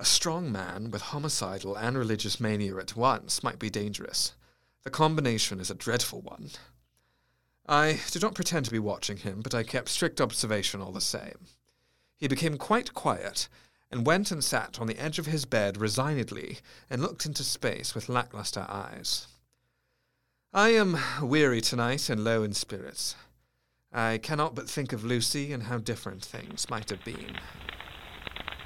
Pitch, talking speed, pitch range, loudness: 120 Hz, 165 wpm, 105-140 Hz, -30 LUFS